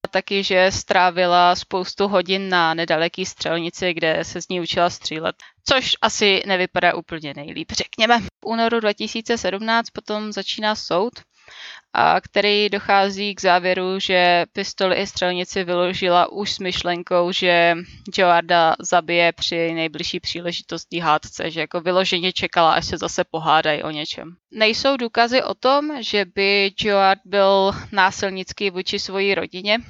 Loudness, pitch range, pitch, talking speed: -19 LUFS, 175-200 Hz, 185 Hz, 135 wpm